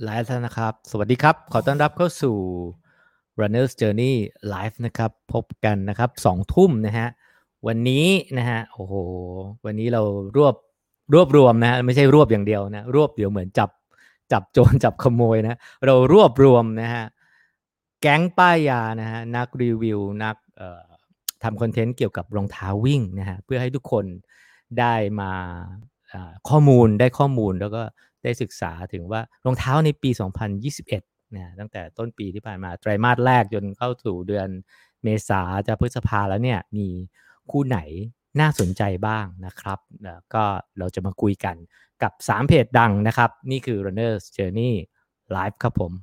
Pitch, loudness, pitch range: 110 Hz, -21 LUFS, 100-125 Hz